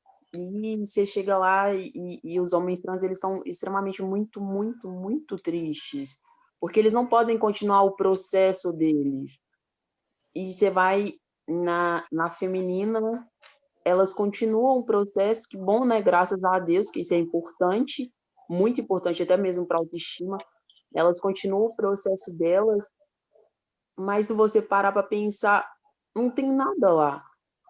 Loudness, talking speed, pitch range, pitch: -25 LUFS, 140 wpm, 180-220 Hz, 195 Hz